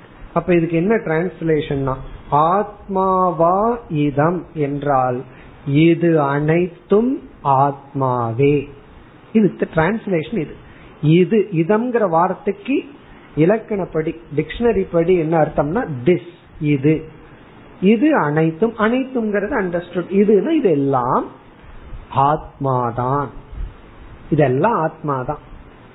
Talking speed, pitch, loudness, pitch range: 65 wpm, 165 Hz, -18 LUFS, 145-195 Hz